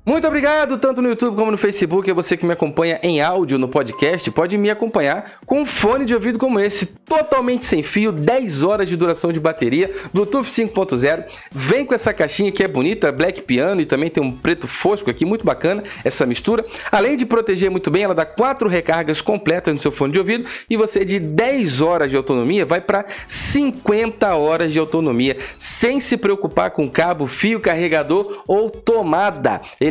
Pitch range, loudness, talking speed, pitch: 160-235 Hz, -17 LUFS, 190 wpm, 200 Hz